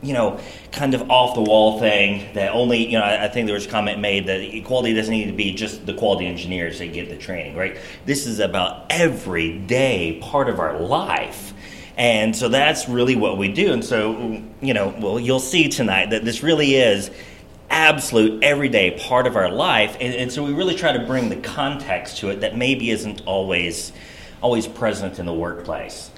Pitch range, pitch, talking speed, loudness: 100-125 Hz, 110 Hz, 200 wpm, -20 LUFS